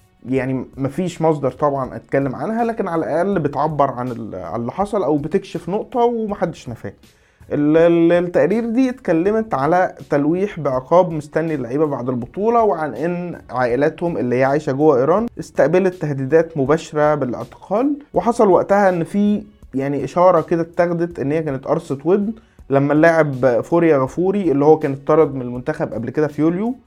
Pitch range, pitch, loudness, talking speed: 140-185 Hz, 160 Hz, -18 LUFS, 150 wpm